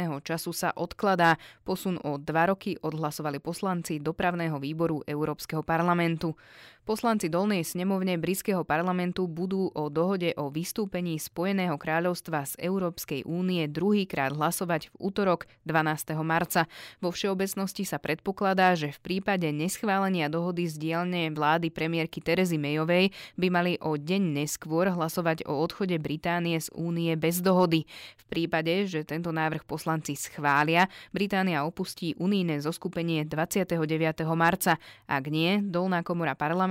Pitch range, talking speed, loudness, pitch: 155-185 Hz, 130 wpm, -28 LUFS, 170 Hz